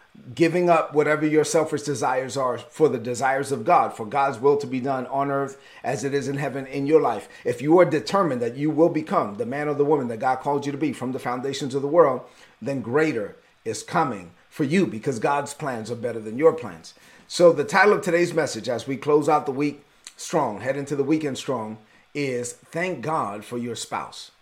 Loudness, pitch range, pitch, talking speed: -23 LUFS, 130-155 Hz, 140 Hz, 225 wpm